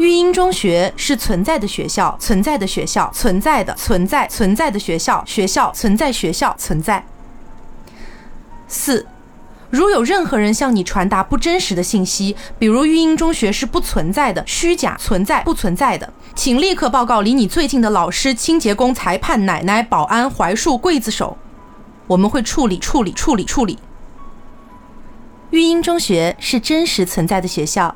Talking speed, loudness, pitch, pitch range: 250 characters per minute, -16 LUFS, 220 Hz, 195-310 Hz